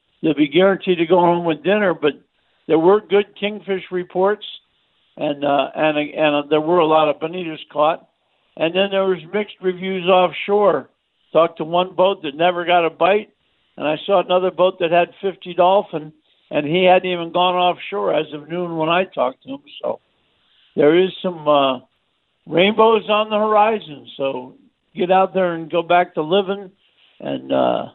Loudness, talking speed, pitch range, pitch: -18 LUFS, 185 wpm, 160-195 Hz, 180 Hz